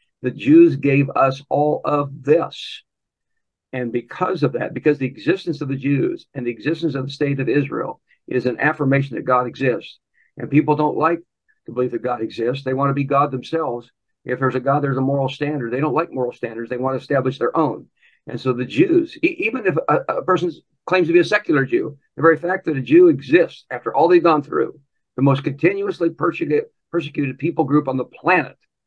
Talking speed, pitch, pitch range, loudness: 215 wpm, 145 Hz, 130-165 Hz, -19 LUFS